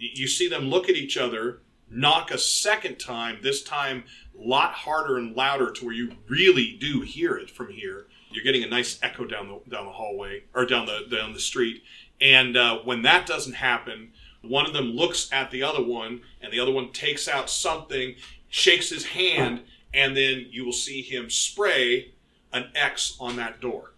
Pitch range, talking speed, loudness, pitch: 125-185 Hz, 200 wpm, -23 LUFS, 135 Hz